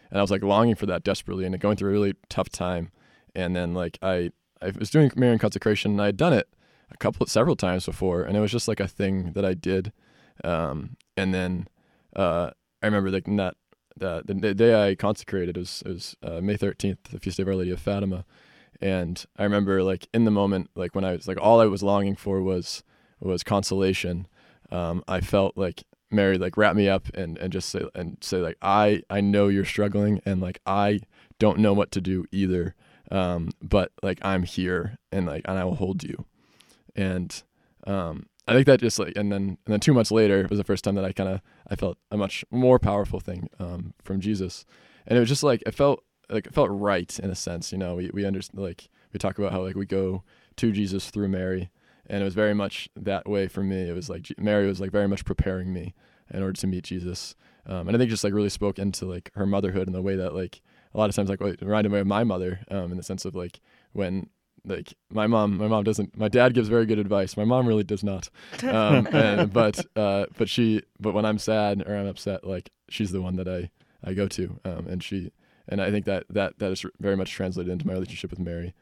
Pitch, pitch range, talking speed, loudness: 95 Hz, 95-105 Hz, 240 wpm, -25 LUFS